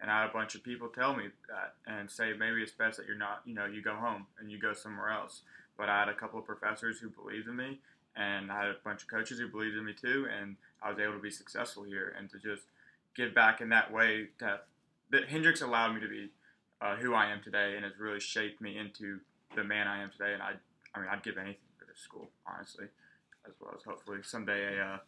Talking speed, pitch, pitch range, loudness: 260 wpm, 105 Hz, 100-110 Hz, -35 LUFS